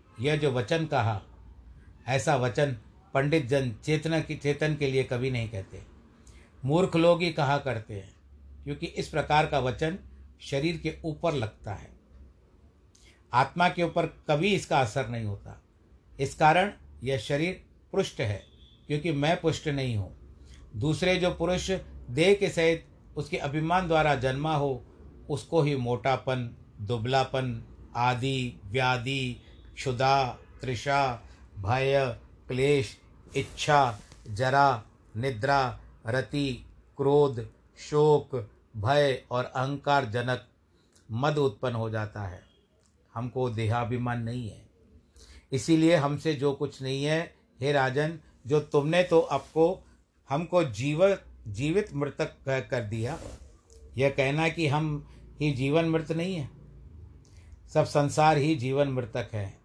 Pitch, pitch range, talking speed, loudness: 135 Hz, 110-150 Hz, 125 wpm, -28 LUFS